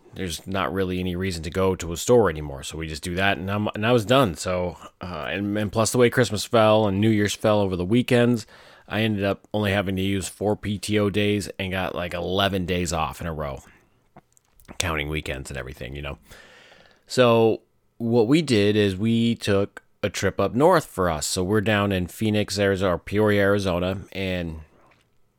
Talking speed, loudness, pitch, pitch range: 205 wpm, -23 LUFS, 100 Hz, 90-105 Hz